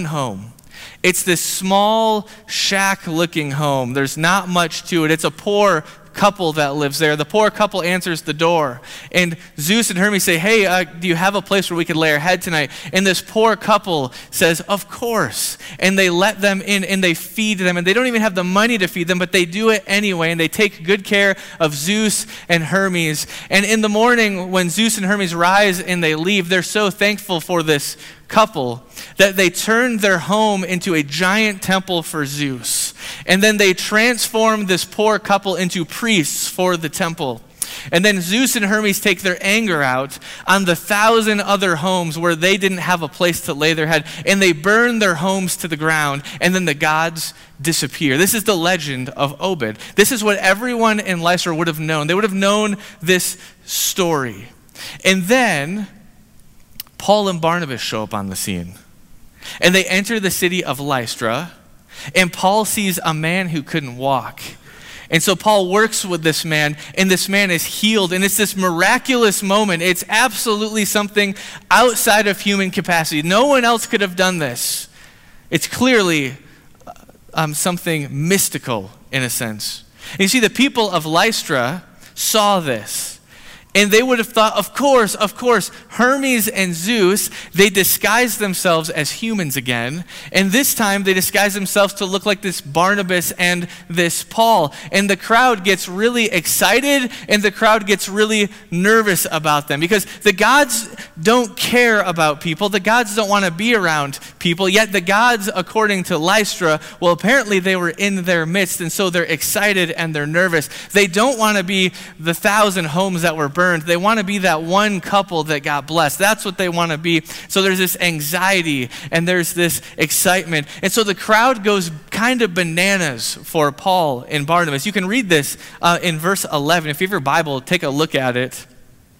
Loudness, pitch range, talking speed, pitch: -16 LUFS, 165-205 Hz, 185 wpm, 185 Hz